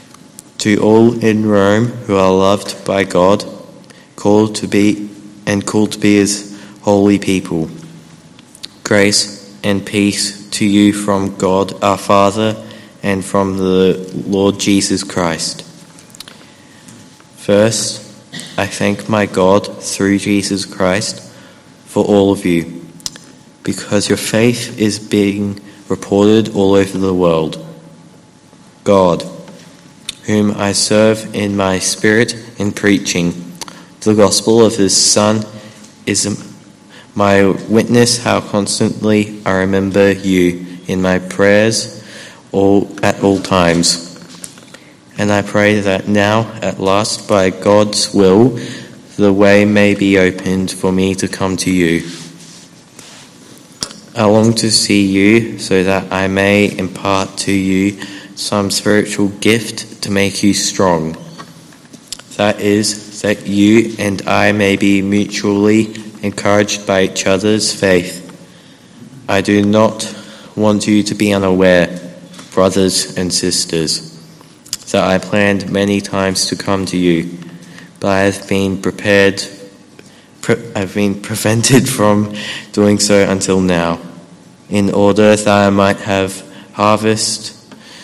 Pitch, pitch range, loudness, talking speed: 100 Hz, 95-105 Hz, -13 LUFS, 125 wpm